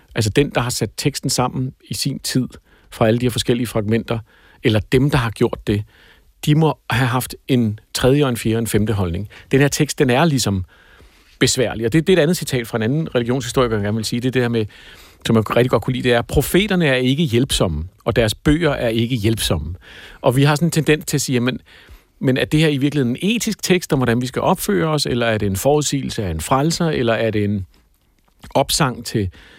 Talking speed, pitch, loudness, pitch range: 240 wpm, 125 Hz, -18 LUFS, 110-145 Hz